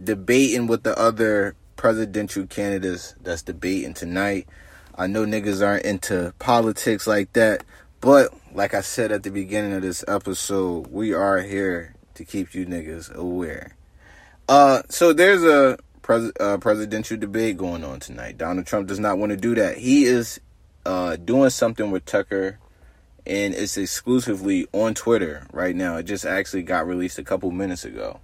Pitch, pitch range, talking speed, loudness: 100 Hz, 95-115 Hz, 165 wpm, -21 LUFS